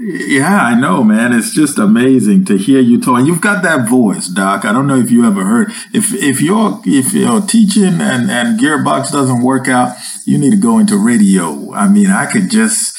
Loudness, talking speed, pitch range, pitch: -11 LUFS, 215 wpm, 160-225 Hz, 210 Hz